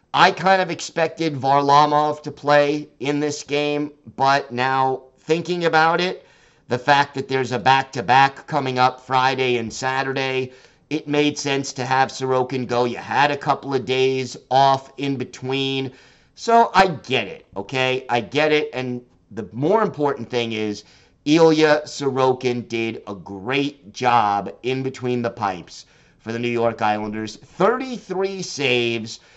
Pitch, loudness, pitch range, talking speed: 135 Hz, -20 LUFS, 125-150 Hz, 155 wpm